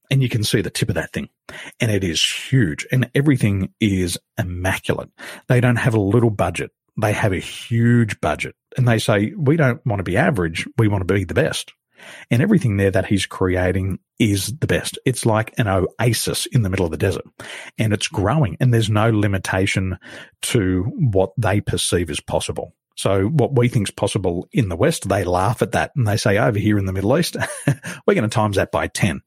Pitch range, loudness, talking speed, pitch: 95-125 Hz, -19 LUFS, 215 wpm, 110 Hz